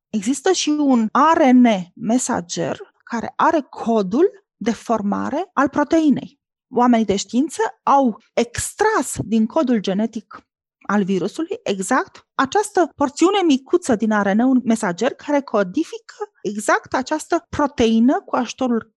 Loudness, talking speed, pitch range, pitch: -19 LUFS, 115 wpm, 225-315 Hz, 260 Hz